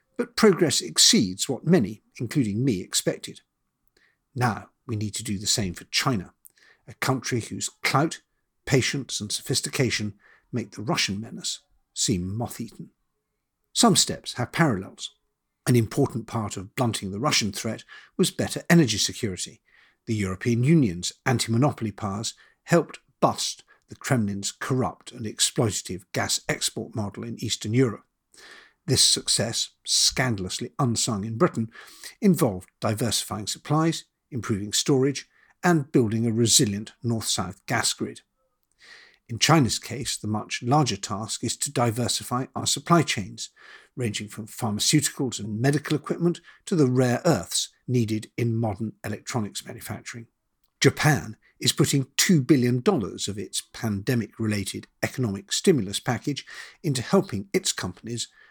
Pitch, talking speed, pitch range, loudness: 120 Hz, 130 wpm, 105-140 Hz, -24 LUFS